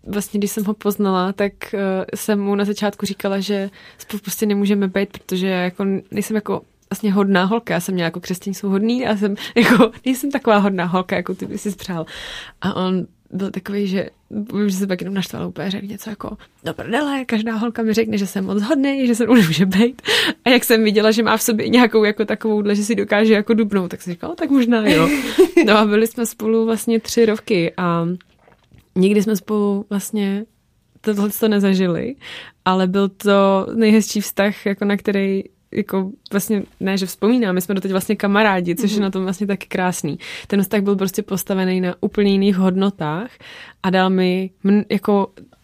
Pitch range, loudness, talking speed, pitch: 195-220 Hz, -18 LUFS, 195 wpm, 205 Hz